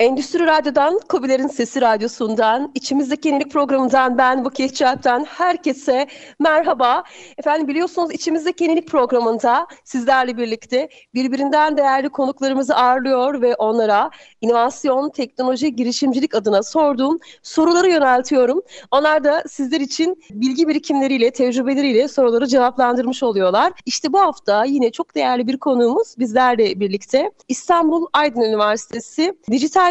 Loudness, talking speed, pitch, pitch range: -17 LUFS, 115 wpm, 270 Hz, 250-305 Hz